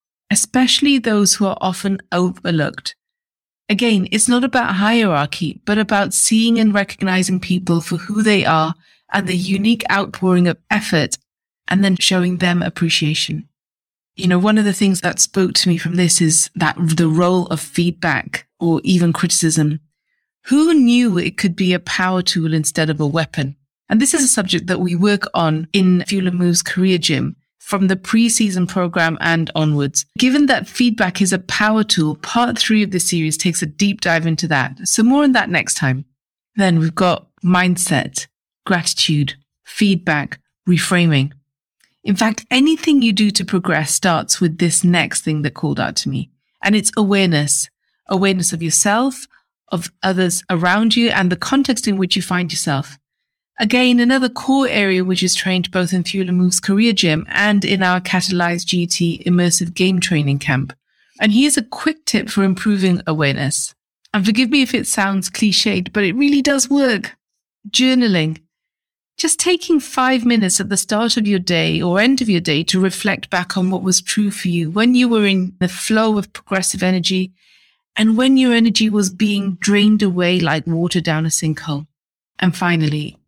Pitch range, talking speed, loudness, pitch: 170-215 Hz, 175 wpm, -16 LUFS, 185 Hz